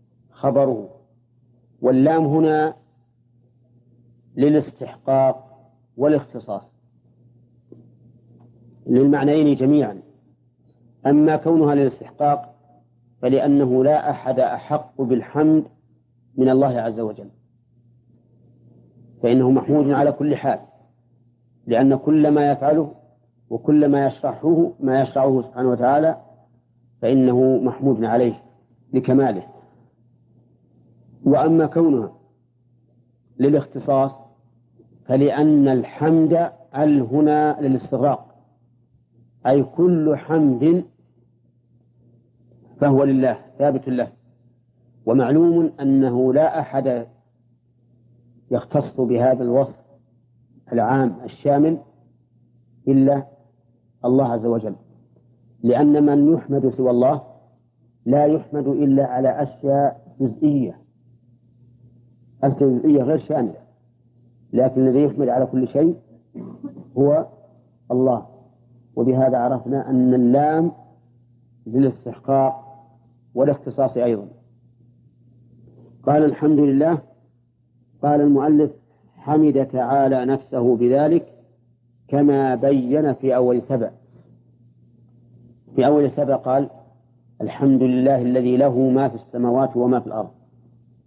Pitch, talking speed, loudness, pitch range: 125 Hz, 80 wpm, -19 LUFS, 120-140 Hz